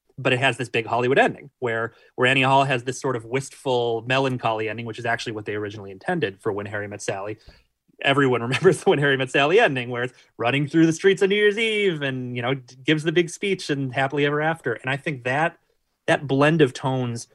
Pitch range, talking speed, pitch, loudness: 120-150 Hz, 230 wpm, 130 Hz, -22 LUFS